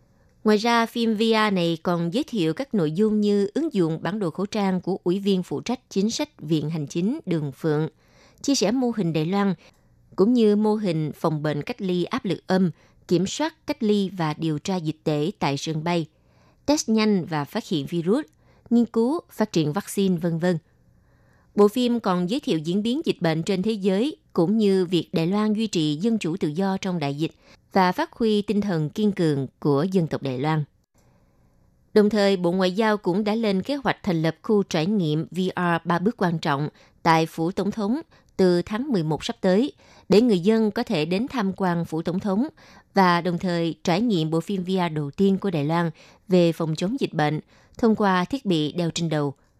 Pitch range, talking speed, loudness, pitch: 165-215 Hz, 210 wpm, -23 LUFS, 185 Hz